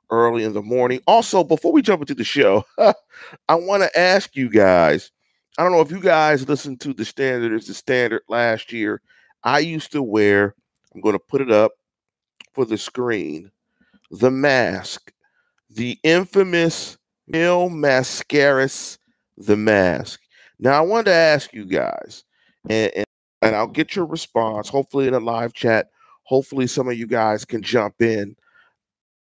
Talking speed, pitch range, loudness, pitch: 165 wpm, 110-160 Hz, -19 LUFS, 130 Hz